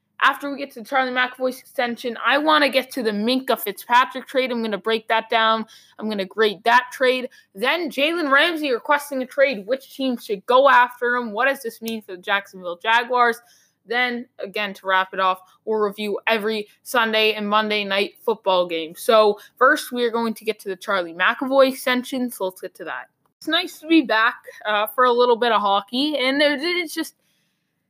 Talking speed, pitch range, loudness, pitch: 205 wpm, 210-260 Hz, -20 LUFS, 235 Hz